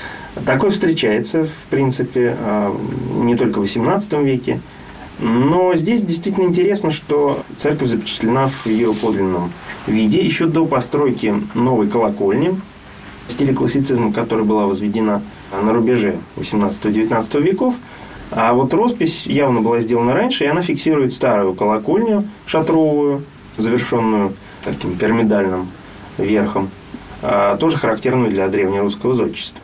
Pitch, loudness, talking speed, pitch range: 120 Hz, -17 LUFS, 115 wpm, 105-150 Hz